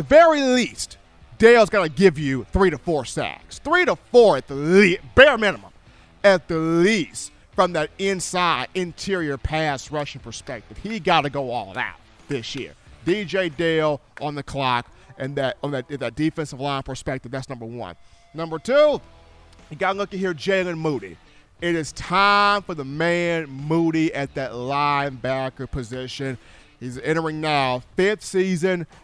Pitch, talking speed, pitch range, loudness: 155 Hz, 155 wpm, 135-185 Hz, -21 LUFS